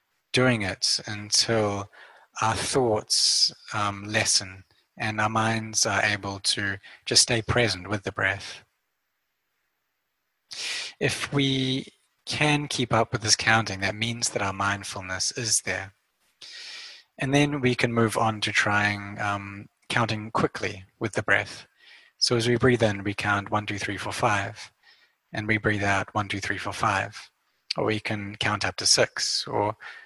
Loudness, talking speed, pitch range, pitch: -25 LUFS, 155 wpm, 100-120 Hz, 105 Hz